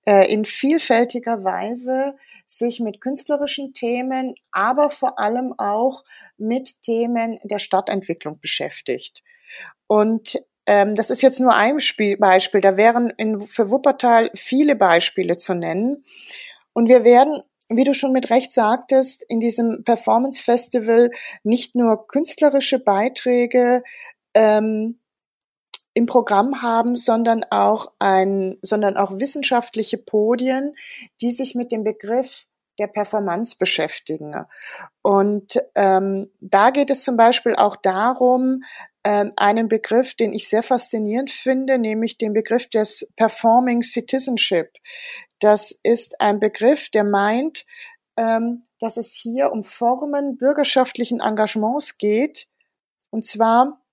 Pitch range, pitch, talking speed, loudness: 215-260 Hz, 235 Hz, 120 wpm, -18 LUFS